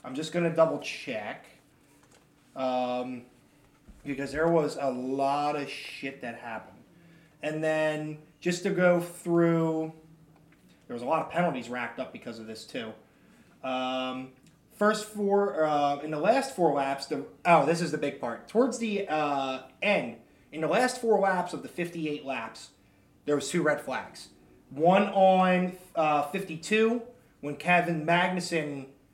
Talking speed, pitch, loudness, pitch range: 150 wpm, 155 Hz, -28 LUFS, 135-175 Hz